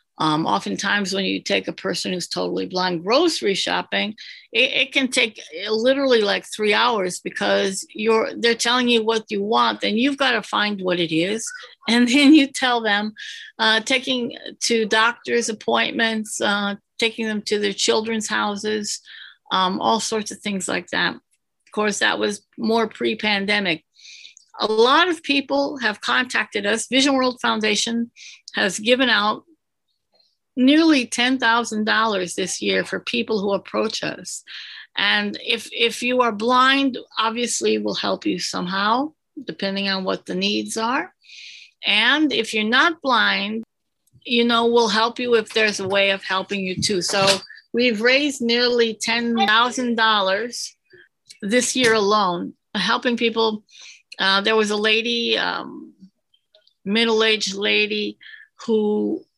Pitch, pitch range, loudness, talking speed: 225 Hz, 205-245 Hz, -20 LUFS, 140 wpm